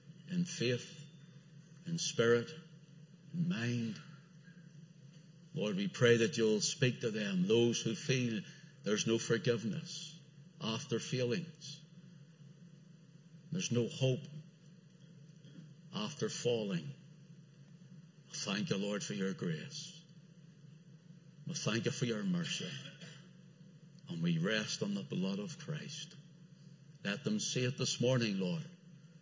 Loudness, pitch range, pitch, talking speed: -36 LUFS, 145-165 Hz, 160 Hz, 115 wpm